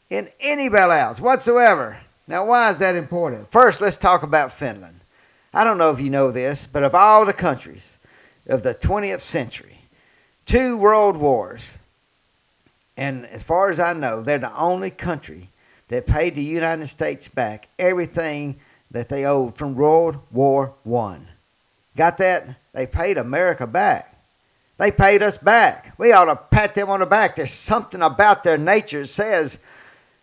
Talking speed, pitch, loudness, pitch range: 165 wpm, 155 Hz, -18 LUFS, 130-195 Hz